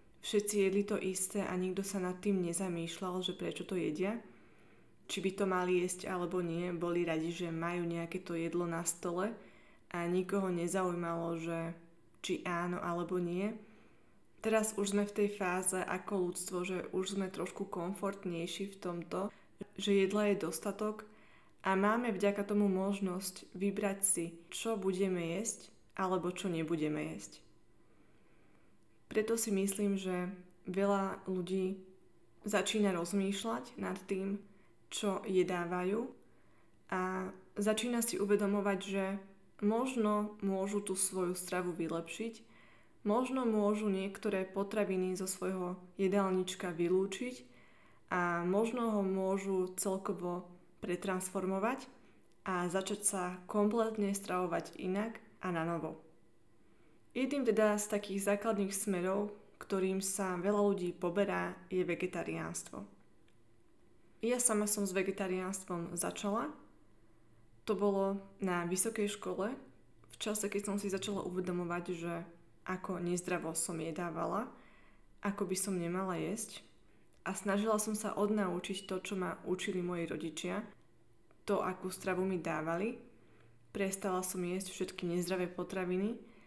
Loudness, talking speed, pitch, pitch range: -36 LUFS, 125 wpm, 190 Hz, 180-205 Hz